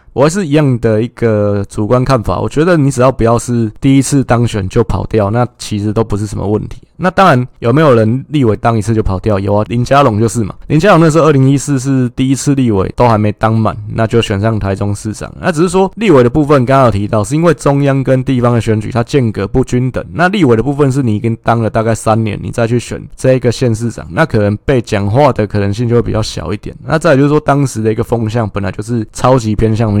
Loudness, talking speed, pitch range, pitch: -12 LUFS, 370 characters per minute, 110-135 Hz, 115 Hz